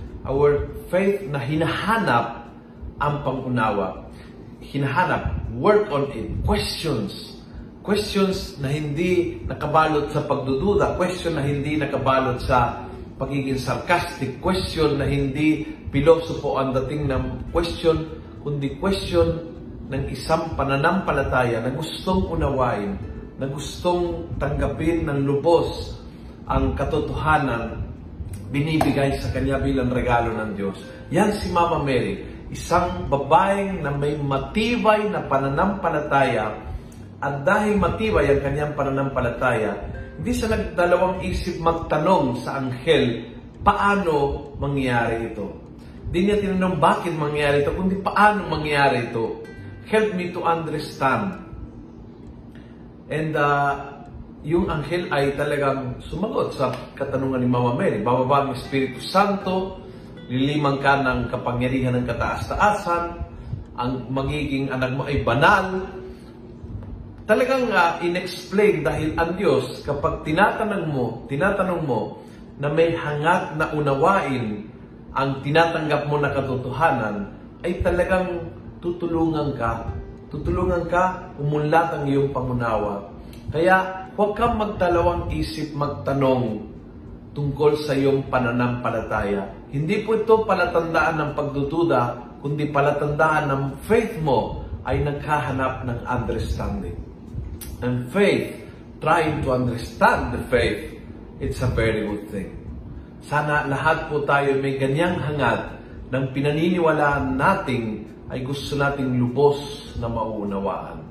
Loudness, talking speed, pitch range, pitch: -22 LUFS, 110 wpm, 120-165 Hz, 140 Hz